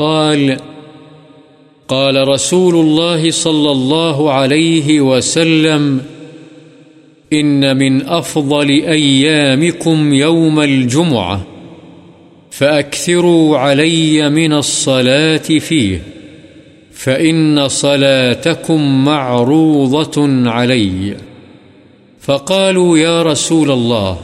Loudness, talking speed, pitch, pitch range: -11 LUFS, 65 wpm, 150 Hz, 135-160 Hz